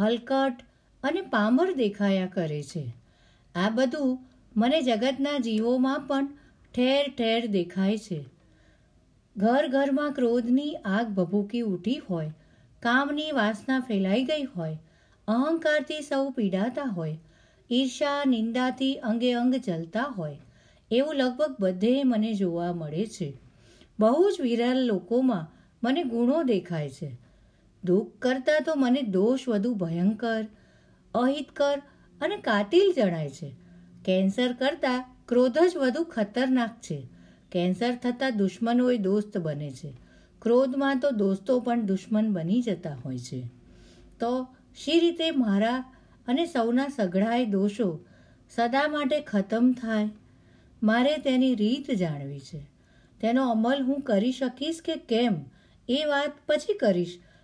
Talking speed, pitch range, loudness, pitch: 120 wpm, 190-265 Hz, -27 LUFS, 235 Hz